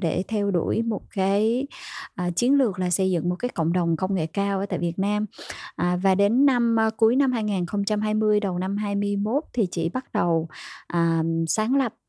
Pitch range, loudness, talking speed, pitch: 180-225 Hz, -24 LUFS, 200 wpm, 200 Hz